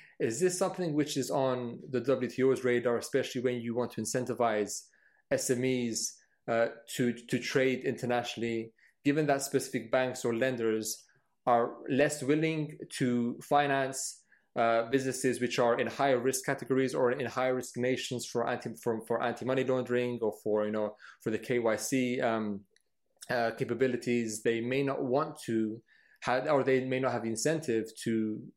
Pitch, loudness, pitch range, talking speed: 125 Hz, -31 LUFS, 115-135 Hz, 155 wpm